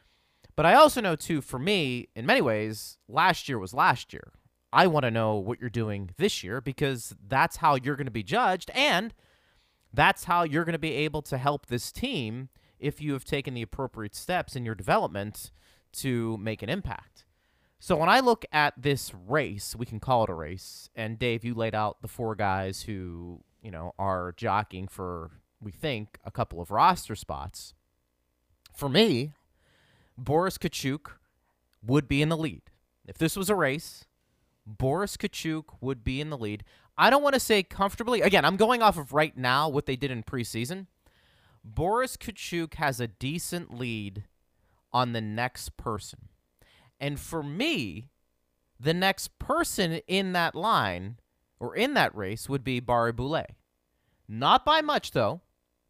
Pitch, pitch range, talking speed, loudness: 125 Hz, 100-155 Hz, 175 wpm, -27 LUFS